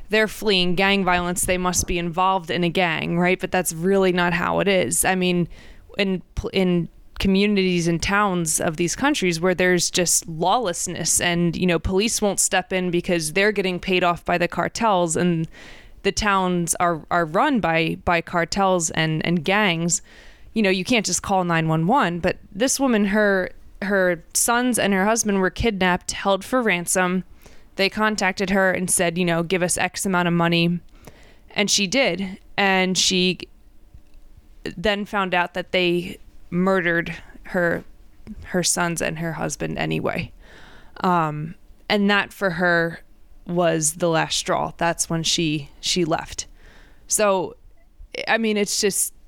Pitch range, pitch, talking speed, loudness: 170-195 Hz, 180 Hz, 160 wpm, -21 LUFS